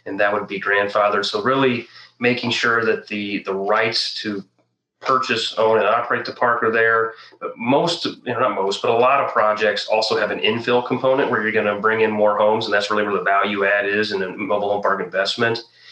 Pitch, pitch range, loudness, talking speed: 105 Hz, 100-115 Hz, -19 LUFS, 220 wpm